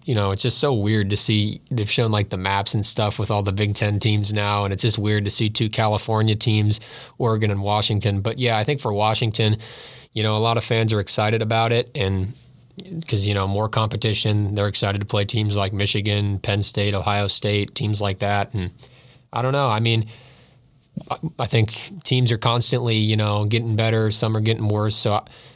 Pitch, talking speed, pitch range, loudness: 110 Hz, 215 wpm, 105-115 Hz, -21 LUFS